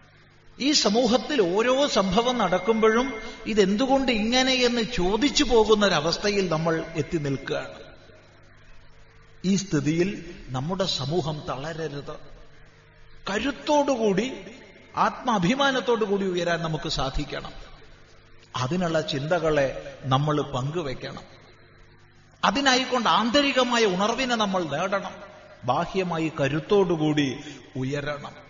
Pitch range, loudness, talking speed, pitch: 145-220 Hz, -24 LUFS, 75 wpm, 170 Hz